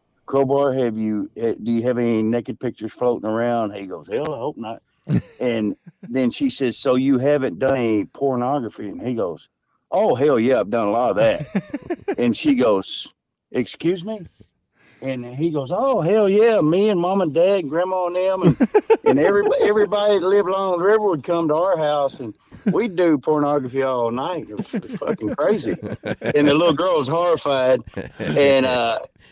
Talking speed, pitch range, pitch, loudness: 185 wpm, 125-190 Hz, 145 Hz, -20 LUFS